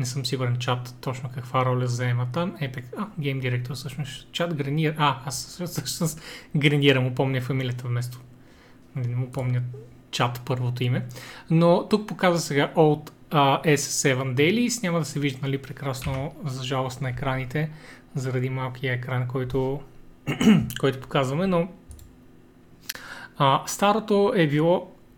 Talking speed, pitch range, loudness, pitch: 145 wpm, 130-155 Hz, -25 LUFS, 135 Hz